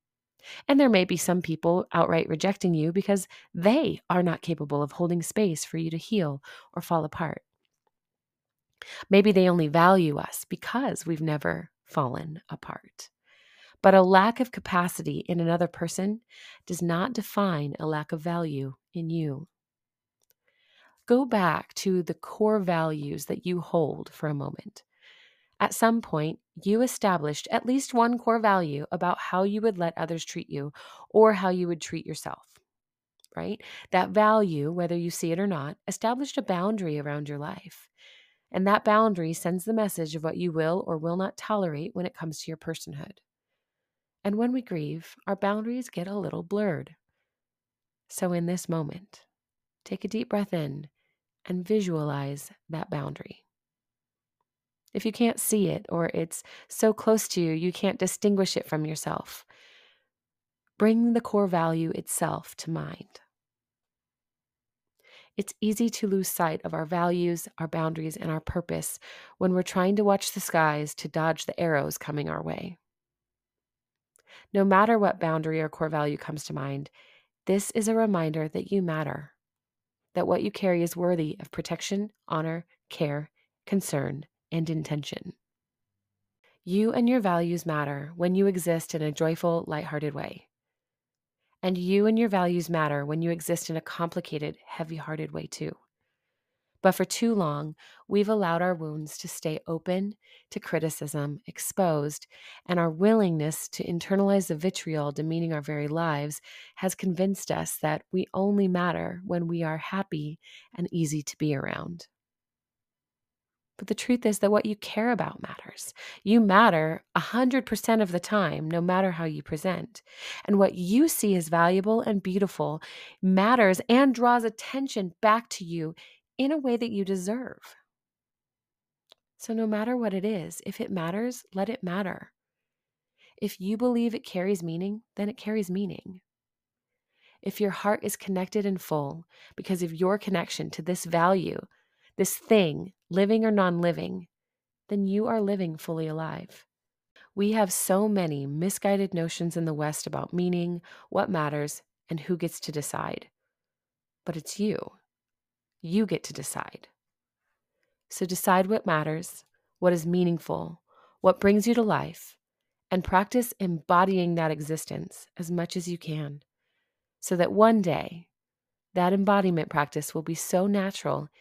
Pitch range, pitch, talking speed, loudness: 160-205 Hz, 180 Hz, 155 wpm, -27 LUFS